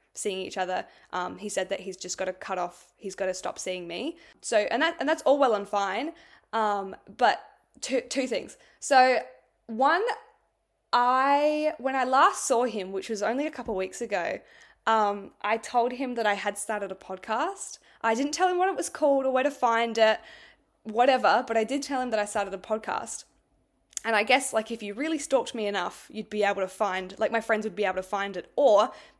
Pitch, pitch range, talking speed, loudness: 225 Hz, 200-270 Hz, 220 wpm, -27 LUFS